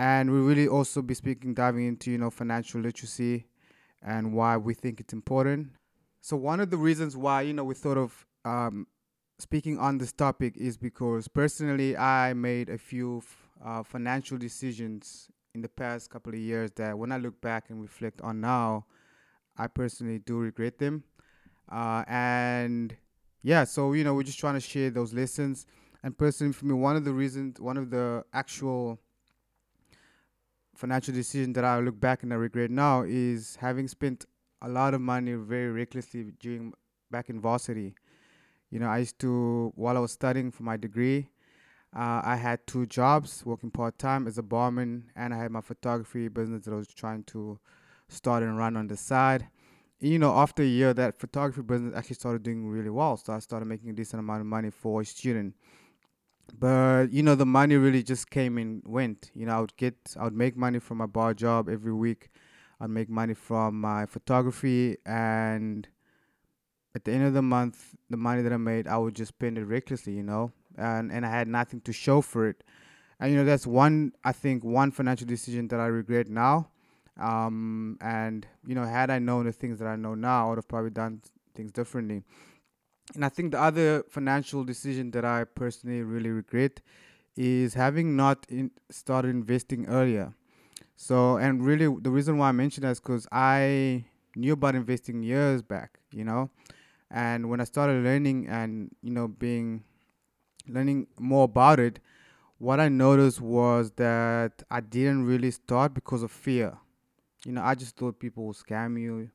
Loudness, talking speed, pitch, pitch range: -28 LUFS, 190 wpm, 120 Hz, 115-130 Hz